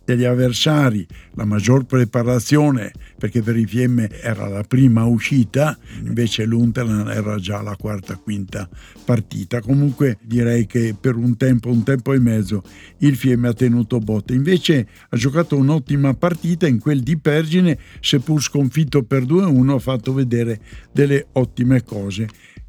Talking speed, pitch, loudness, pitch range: 145 wpm, 125 Hz, -18 LUFS, 110-135 Hz